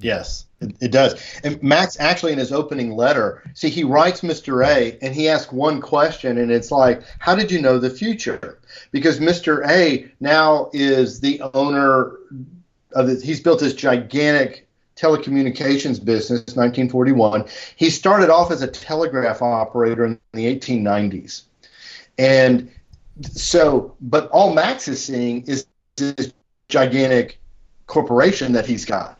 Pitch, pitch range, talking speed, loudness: 135 Hz, 125-155 Hz, 150 wpm, -18 LUFS